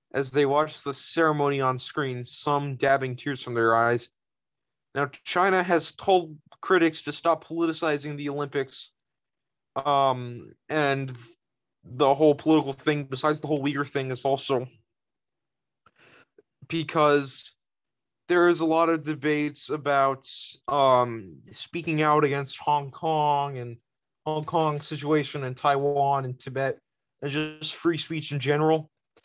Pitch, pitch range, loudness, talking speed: 145 Hz, 135-155 Hz, -25 LUFS, 130 wpm